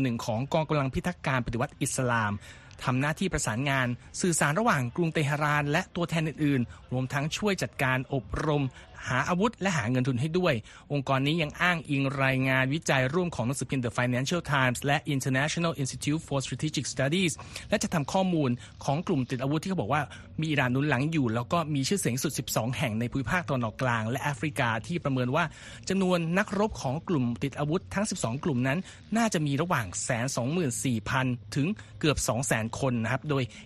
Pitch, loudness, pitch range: 140 Hz, -28 LUFS, 125-160 Hz